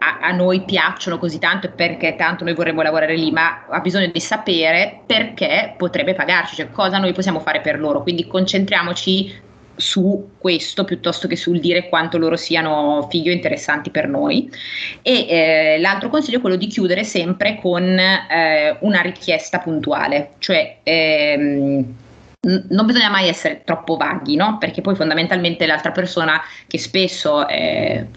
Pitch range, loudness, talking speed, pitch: 160-190 Hz, -17 LUFS, 160 wpm, 175 Hz